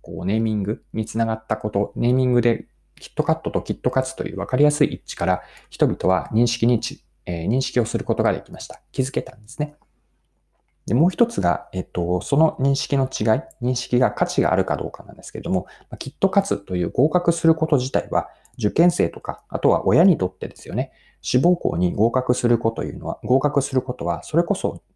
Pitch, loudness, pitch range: 125 Hz, -22 LUFS, 110-145 Hz